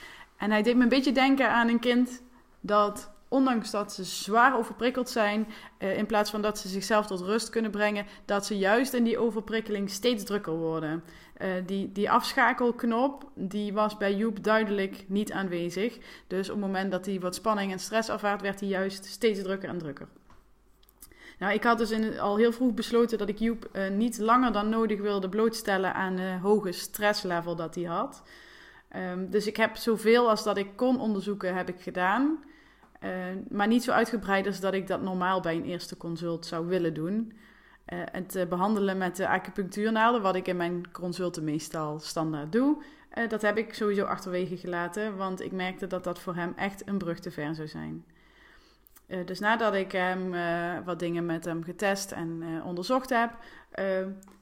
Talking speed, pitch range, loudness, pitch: 195 wpm, 185-225 Hz, -29 LUFS, 200 Hz